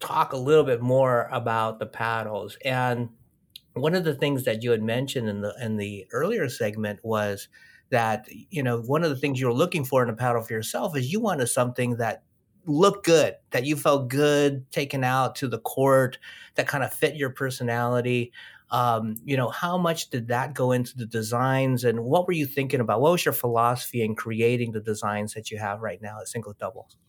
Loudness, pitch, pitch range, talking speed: -25 LUFS, 125 Hz, 115-140 Hz, 210 wpm